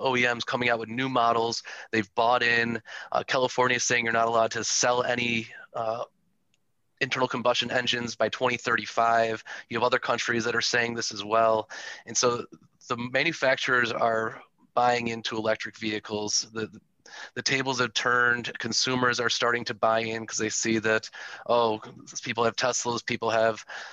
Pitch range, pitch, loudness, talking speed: 115-125 Hz, 115 Hz, -26 LUFS, 165 wpm